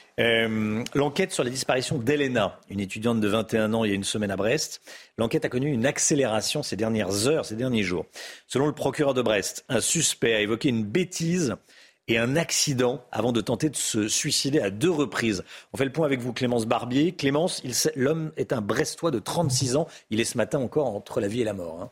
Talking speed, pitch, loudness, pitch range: 220 wpm, 125 Hz, -25 LUFS, 110-150 Hz